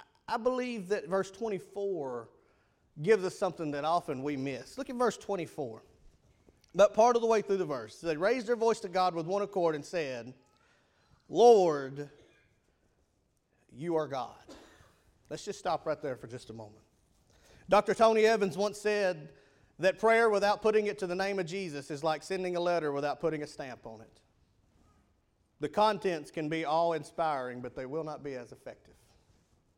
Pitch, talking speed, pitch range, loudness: 170 Hz, 175 wpm, 140-205 Hz, -31 LUFS